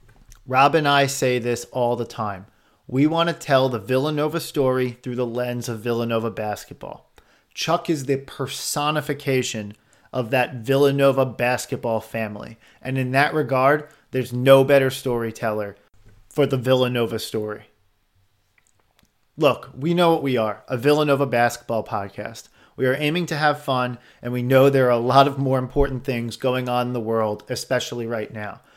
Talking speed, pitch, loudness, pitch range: 160 wpm, 125 Hz, -21 LUFS, 115-140 Hz